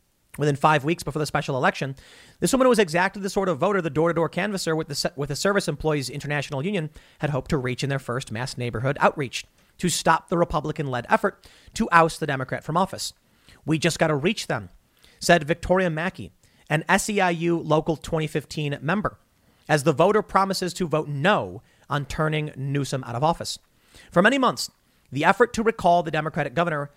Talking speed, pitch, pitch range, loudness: 195 wpm, 160 Hz, 145-180 Hz, -24 LUFS